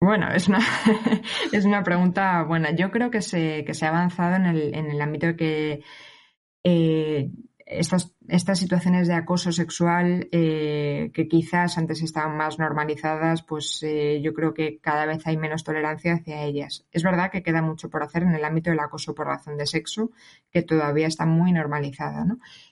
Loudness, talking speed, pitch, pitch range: -24 LUFS, 185 wpm, 165 Hz, 155-180 Hz